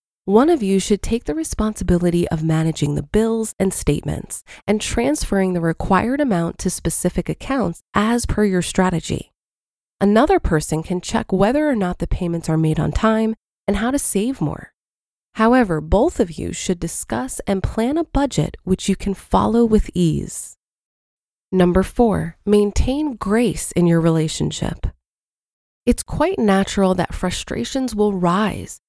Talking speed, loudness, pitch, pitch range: 150 wpm, -19 LUFS, 195 Hz, 175-225 Hz